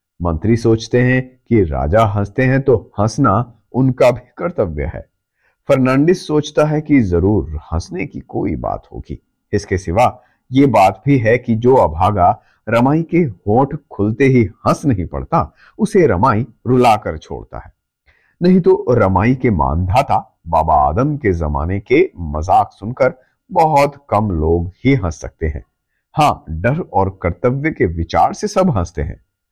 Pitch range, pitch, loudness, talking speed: 95-135 Hz, 115 Hz, -15 LUFS, 150 wpm